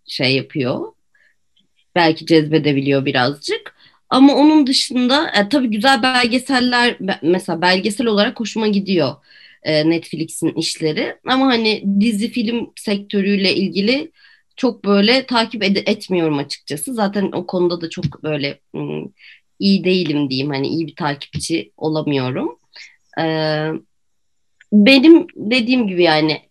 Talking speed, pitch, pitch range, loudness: 110 wpm, 195 Hz, 155-240 Hz, -16 LUFS